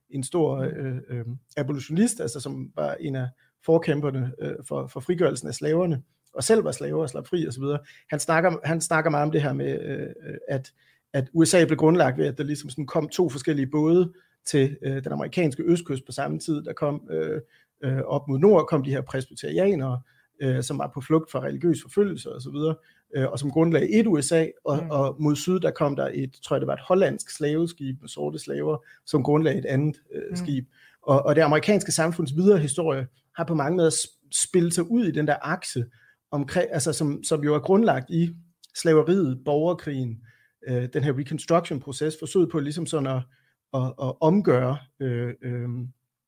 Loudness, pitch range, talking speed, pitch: -25 LUFS, 135-165 Hz, 190 wpm, 150 Hz